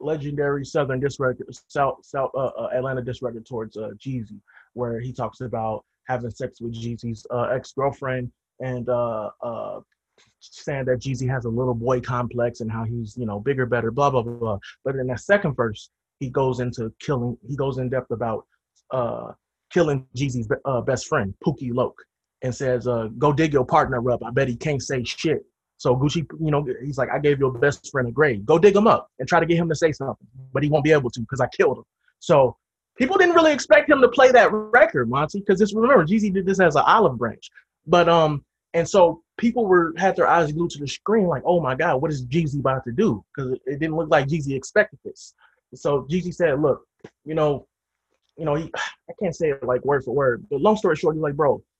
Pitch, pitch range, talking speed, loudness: 135 Hz, 125-160 Hz, 220 wpm, -22 LUFS